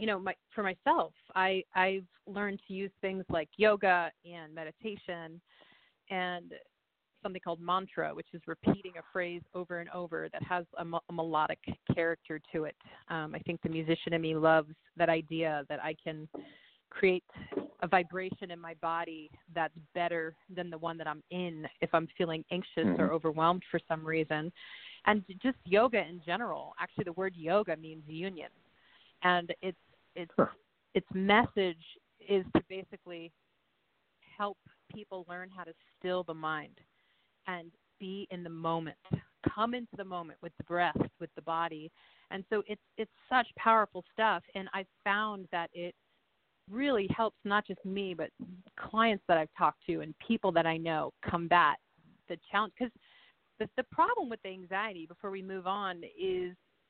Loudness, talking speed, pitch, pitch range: -34 LUFS, 165 wpm, 180 Hz, 165-200 Hz